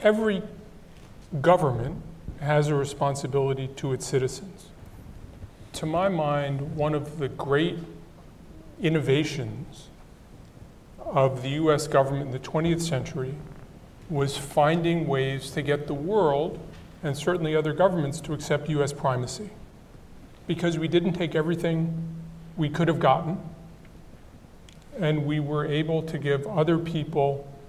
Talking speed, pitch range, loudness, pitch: 120 wpm, 140-165 Hz, -26 LUFS, 150 Hz